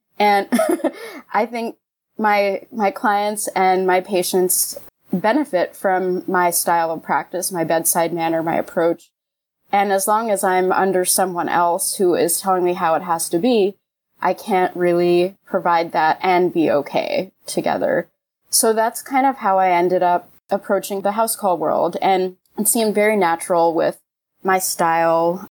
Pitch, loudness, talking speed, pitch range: 185 Hz, -18 LUFS, 155 wpm, 175-205 Hz